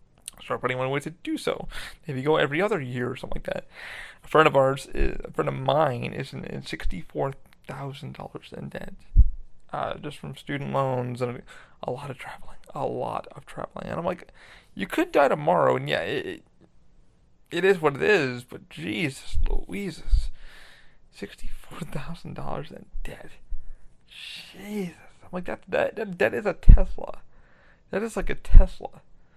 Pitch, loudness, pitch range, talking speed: 150 Hz, -27 LUFS, 130-185 Hz, 170 wpm